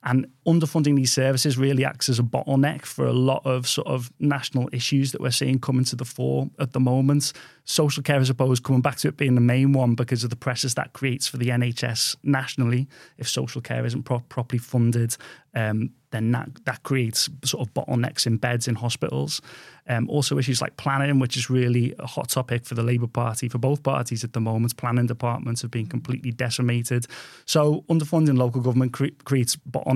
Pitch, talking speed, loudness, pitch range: 130 Hz, 205 wpm, -23 LUFS, 120-135 Hz